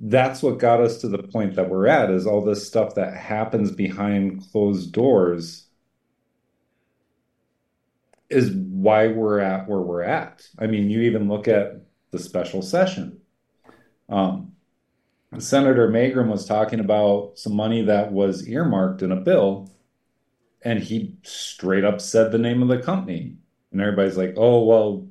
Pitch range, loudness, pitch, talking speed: 95-120 Hz, -21 LUFS, 105 Hz, 155 wpm